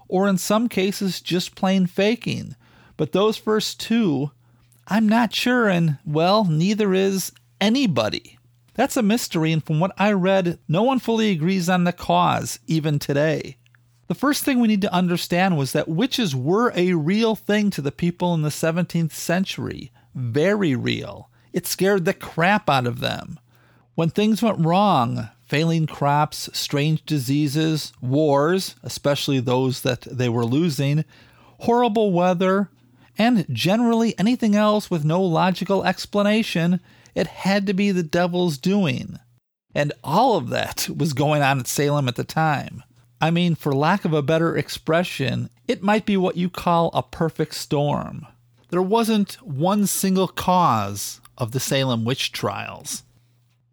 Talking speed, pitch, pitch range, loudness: 155 wpm, 170 Hz, 140-195 Hz, -21 LUFS